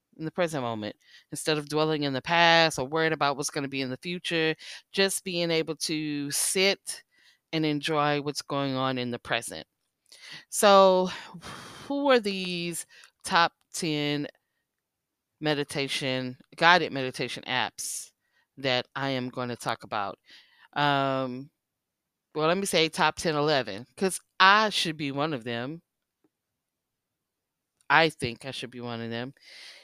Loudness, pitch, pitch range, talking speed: -26 LUFS, 150 Hz, 130-165 Hz, 145 wpm